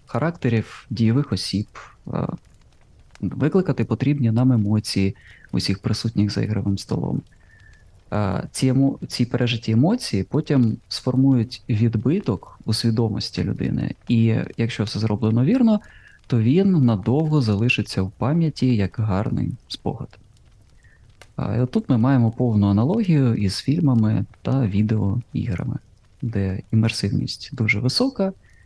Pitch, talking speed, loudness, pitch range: 115 Hz, 105 wpm, -21 LUFS, 105-130 Hz